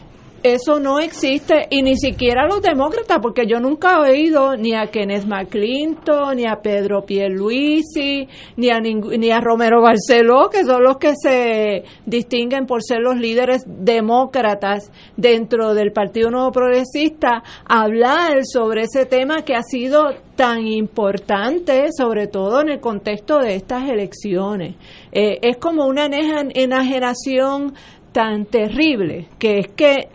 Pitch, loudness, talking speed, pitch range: 245 Hz, -17 LUFS, 140 wpm, 220-275 Hz